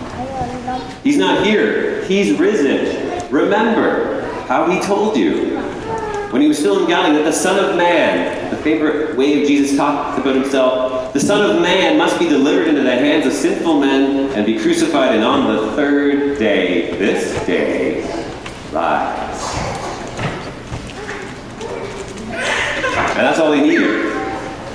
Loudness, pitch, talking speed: -16 LUFS, 155 Hz, 145 wpm